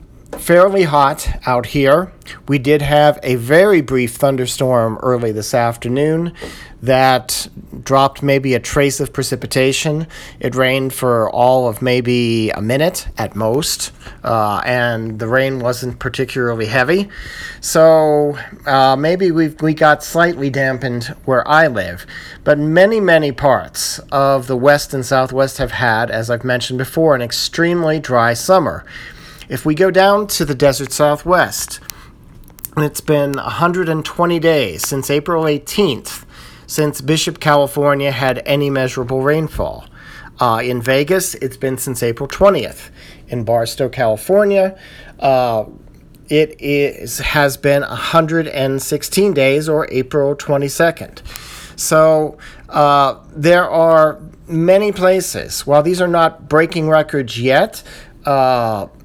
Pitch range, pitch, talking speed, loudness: 125-155 Hz, 140 Hz, 125 wpm, -15 LUFS